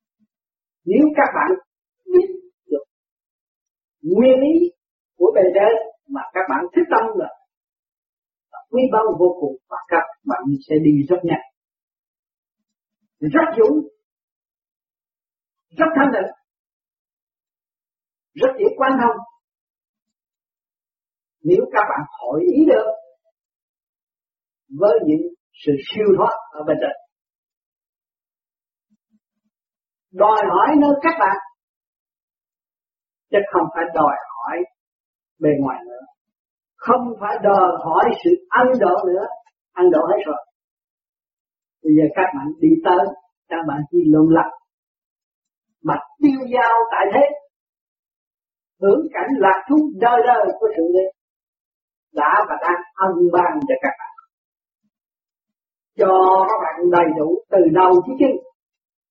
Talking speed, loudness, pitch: 120 wpm, -17 LUFS, 230 Hz